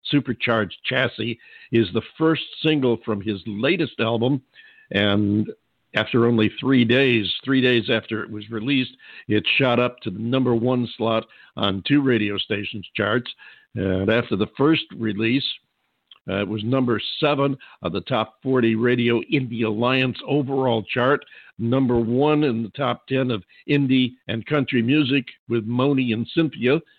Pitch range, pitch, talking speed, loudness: 110-130 Hz, 120 Hz, 150 wpm, -22 LUFS